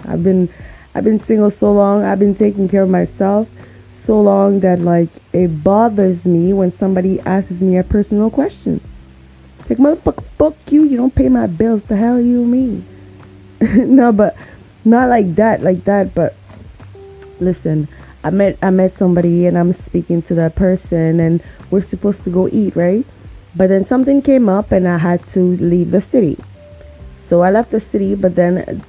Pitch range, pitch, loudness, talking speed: 175-210 Hz, 190 Hz, -14 LUFS, 180 wpm